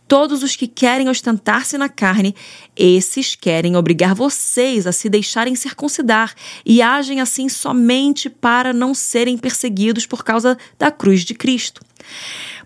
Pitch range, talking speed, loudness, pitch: 220-270 Hz, 140 wpm, -15 LUFS, 245 Hz